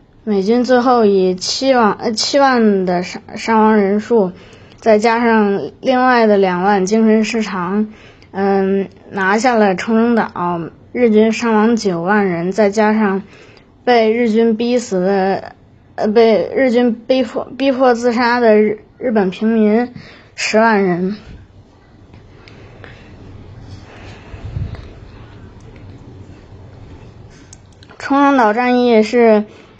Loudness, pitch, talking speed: -14 LUFS, 210 Hz, 150 characters per minute